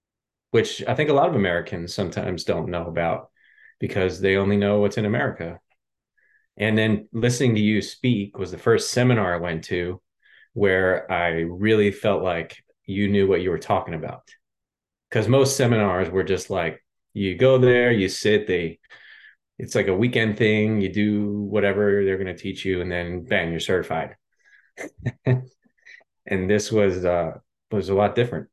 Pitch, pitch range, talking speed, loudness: 100 Hz, 95-110 Hz, 170 wpm, -22 LUFS